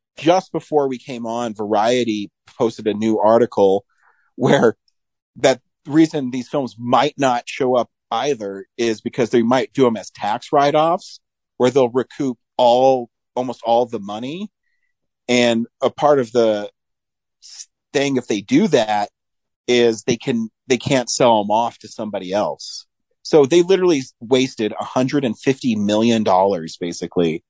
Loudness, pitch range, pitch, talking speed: -18 LUFS, 110-140 Hz, 125 Hz, 140 wpm